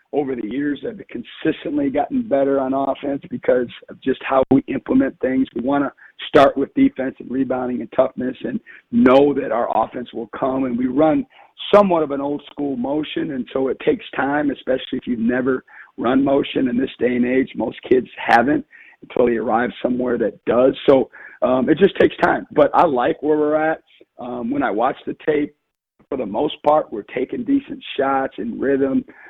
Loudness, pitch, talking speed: -19 LUFS, 140 Hz, 195 wpm